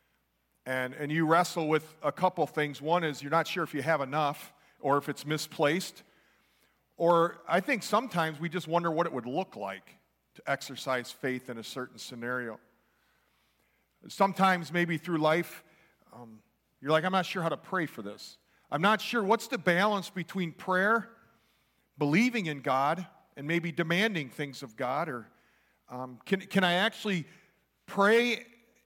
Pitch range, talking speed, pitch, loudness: 140-190 Hz, 165 wpm, 165 Hz, -30 LUFS